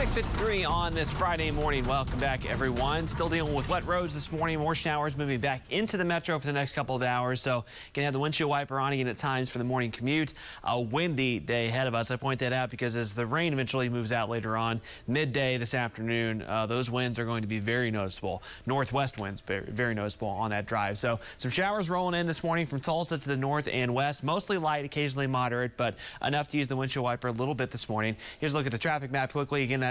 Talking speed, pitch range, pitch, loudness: 240 wpm, 120-150 Hz, 130 Hz, -30 LUFS